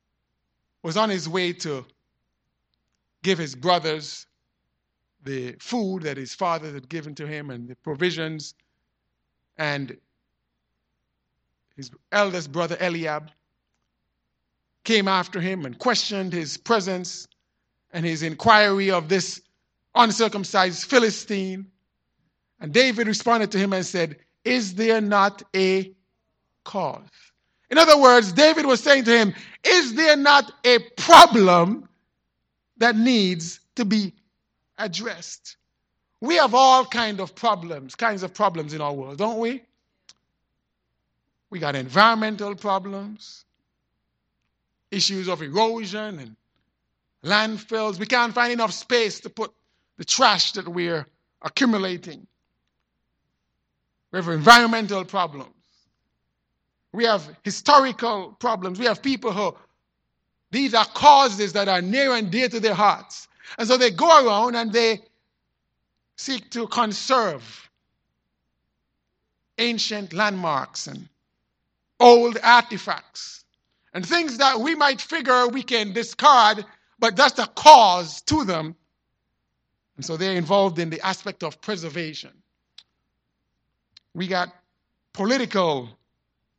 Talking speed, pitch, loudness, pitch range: 115 wpm, 195 Hz, -20 LUFS, 165-230 Hz